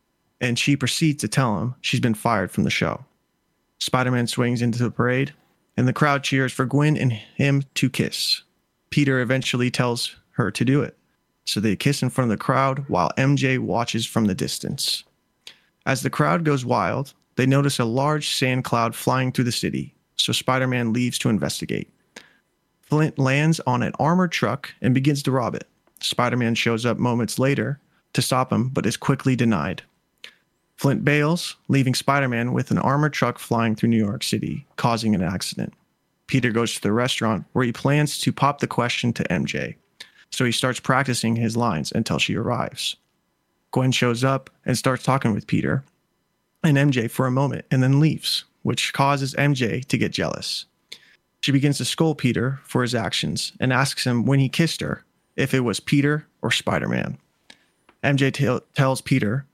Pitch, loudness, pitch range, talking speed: 130 Hz, -22 LUFS, 120-140 Hz, 185 wpm